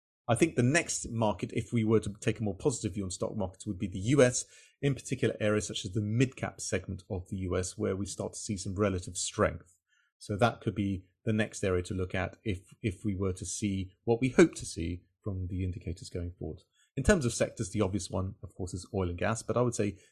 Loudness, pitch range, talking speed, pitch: -32 LUFS, 95-115 Hz, 250 wpm, 105 Hz